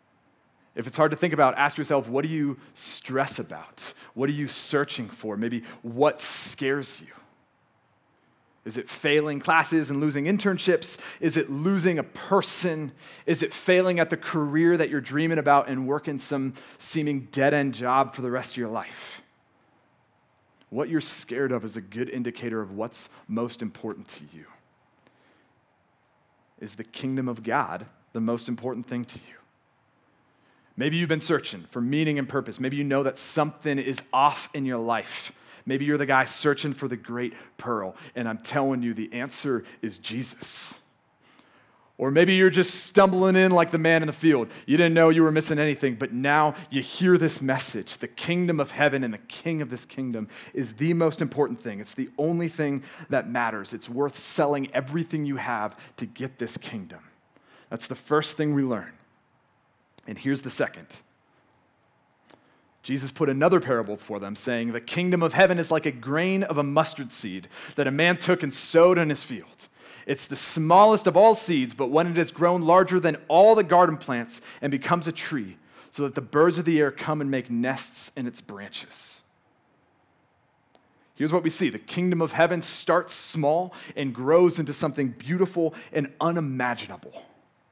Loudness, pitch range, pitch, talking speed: -24 LUFS, 130-165 Hz, 145 Hz, 180 wpm